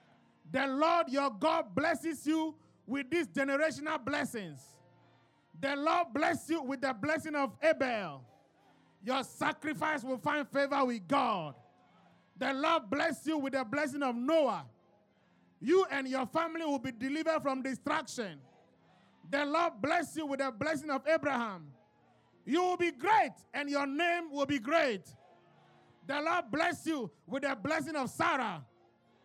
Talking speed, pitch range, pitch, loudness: 150 wpm, 265-320 Hz, 285 Hz, -33 LUFS